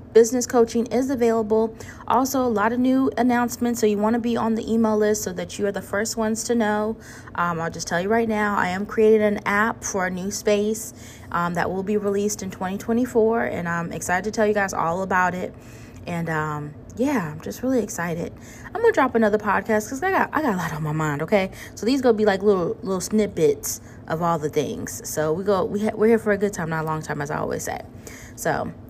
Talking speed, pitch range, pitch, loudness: 245 wpm, 170-225 Hz, 210 Hz, -22 LUFS